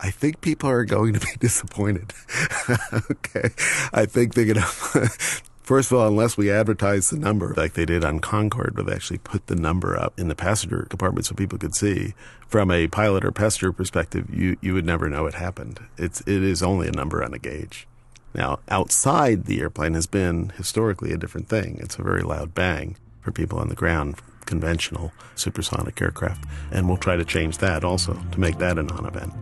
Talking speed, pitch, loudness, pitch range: 200 wpm, 100 Hz, -23 LUFS, 85-110 Hz